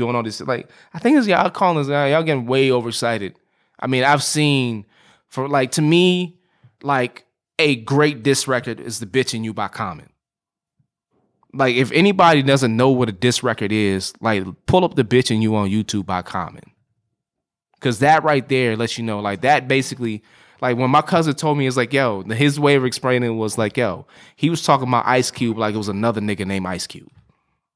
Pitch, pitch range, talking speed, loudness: 125 Hz, 110-145 Hz, 210 wpm, -18 LUFS